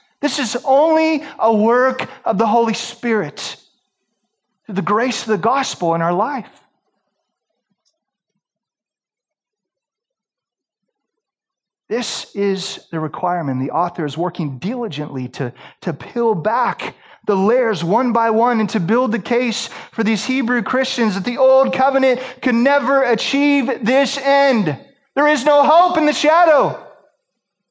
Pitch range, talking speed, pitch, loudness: 205-270 Hz, 130 wpm, 235 Hz, -17 LUFS